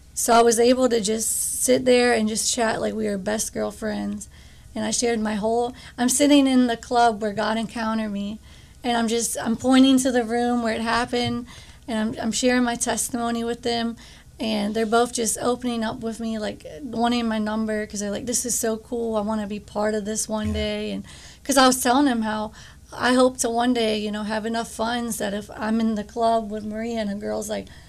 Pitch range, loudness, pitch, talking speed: 215-240 Hz, -22 LUFS, 225 Hz, 230 wpm